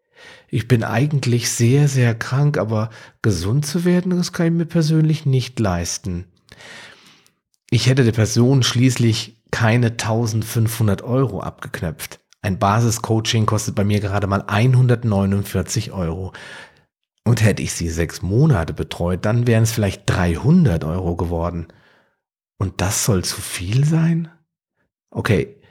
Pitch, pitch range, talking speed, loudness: 115 Hz, 100-130 Hz, 130 wpm, -19 LUFS